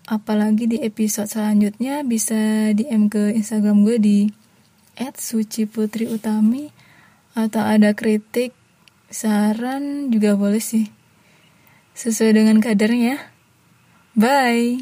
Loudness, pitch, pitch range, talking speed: -19 LUFS, 220 Hz, 215-230 Hz, 90 wpm